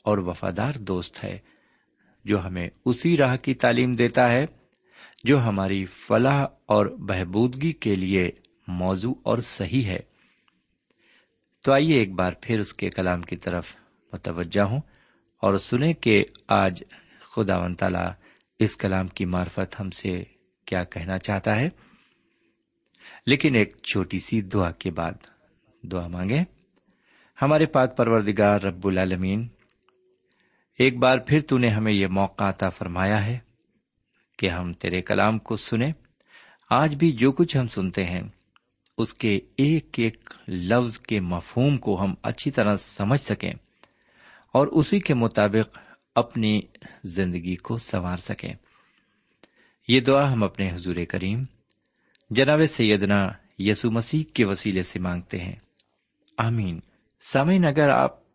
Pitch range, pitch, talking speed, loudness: 95-125 Hz, 105 Hz, 135 wpm, -24 LUFS